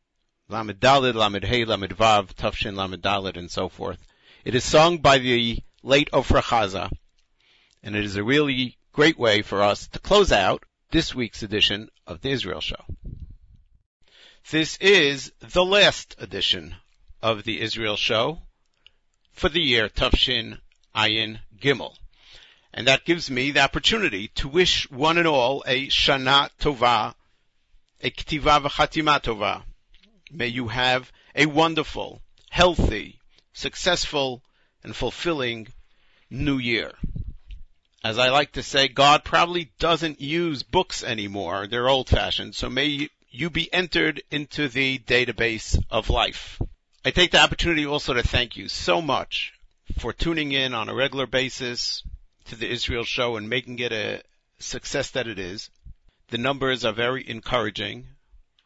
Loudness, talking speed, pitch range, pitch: -22 LUFS, 145 wpm, 110-150 Hz, 125 Hz